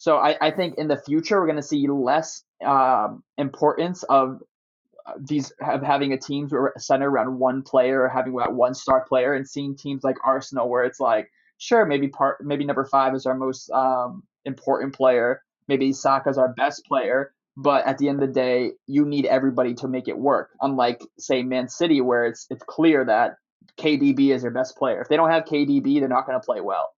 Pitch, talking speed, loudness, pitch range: 135 Hz, 210 wpm, -22 LUFS, 130-145 Hz